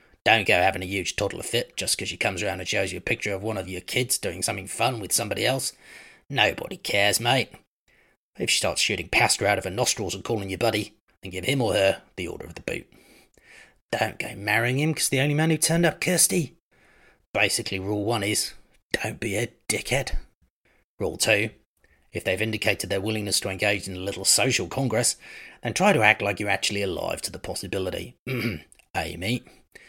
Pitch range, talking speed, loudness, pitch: 95-125 Hz, 205 wpm, -24 LUFS, 105 Hz